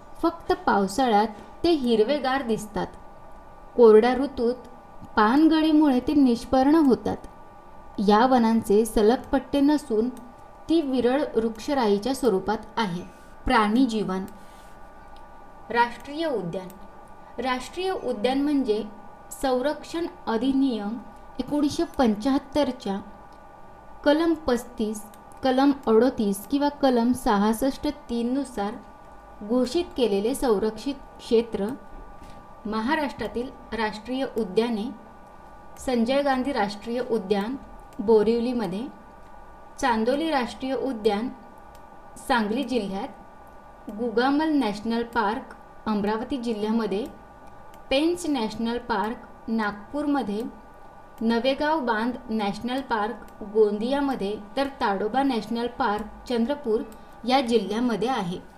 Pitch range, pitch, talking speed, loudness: 220-275 Hz, 240 Hz, 80 wpm, -24 LUFS